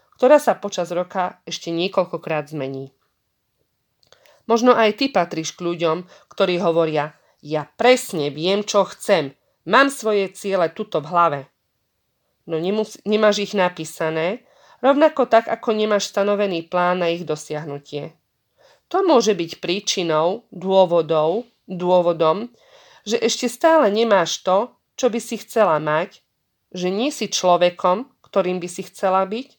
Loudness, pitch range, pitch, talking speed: -20 LUFS, 165-220 Hz, 185 Hz, 130 wpm